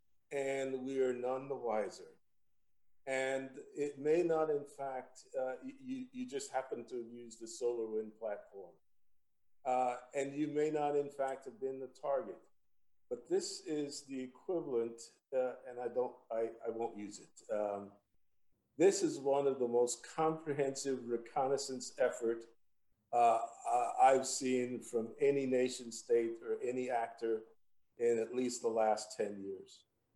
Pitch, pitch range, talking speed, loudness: 130 Hz, 115-145 Hz, 150 wpm, -37 LUFS